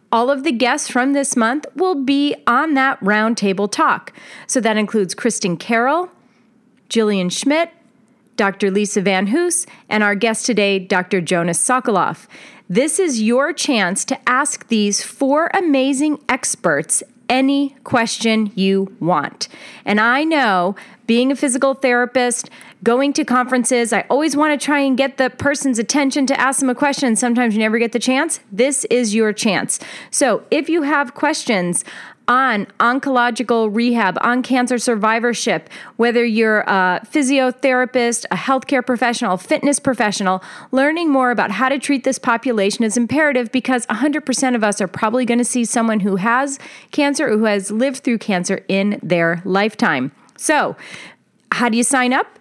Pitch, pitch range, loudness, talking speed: 245 Hz, 220-275 Hz, -17 LUFS, 160 wpm